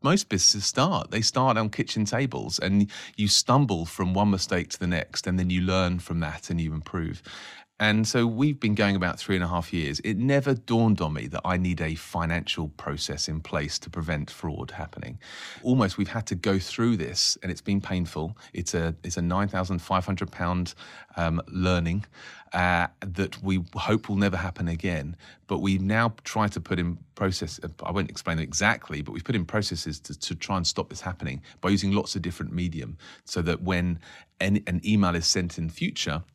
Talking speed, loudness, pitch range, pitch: 200 wpm, -27 LUFS, 85-105 Hz, 95 Hz